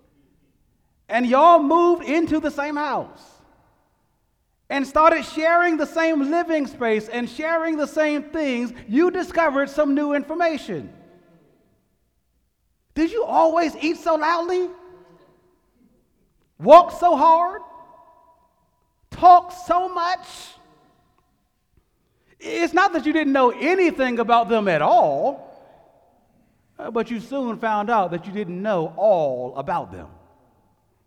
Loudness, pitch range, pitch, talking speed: -19 LUFS, 225-335 Hz, 305 Hz, 115 wpm